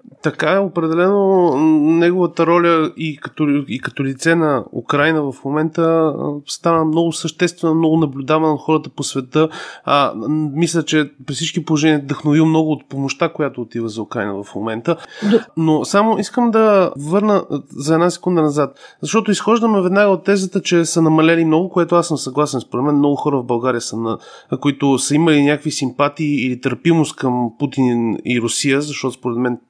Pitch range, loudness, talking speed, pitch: 140-170 Hz, -16 LUFS, 170 wpm, 155 Hz